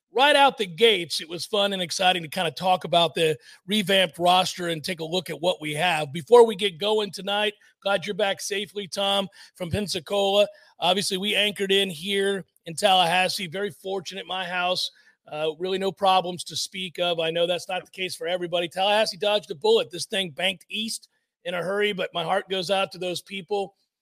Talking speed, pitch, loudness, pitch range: 205 wpm, 190 Hz, -24 LUFS, 175-200 Hz